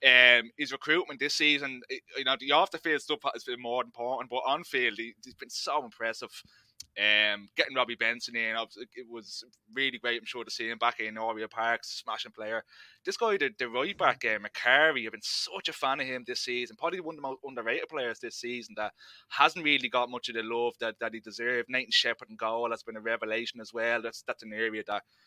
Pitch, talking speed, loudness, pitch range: 120 Hz, 235 wpm, -29 LUFS, 115-130 Hz